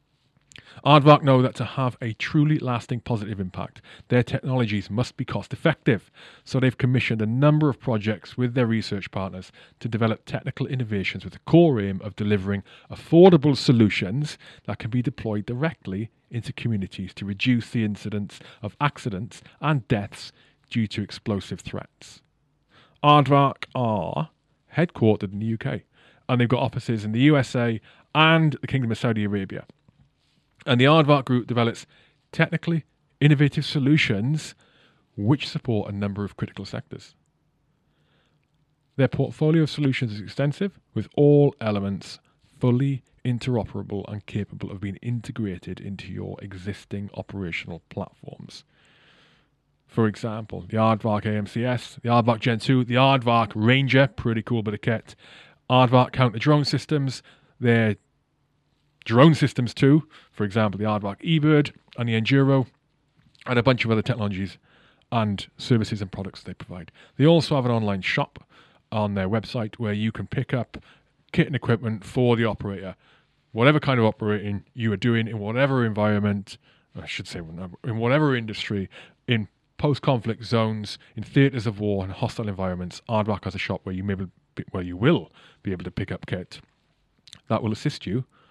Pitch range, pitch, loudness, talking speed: 105-135 Hz, 120 Hz, -23 LUFS, 155 wpm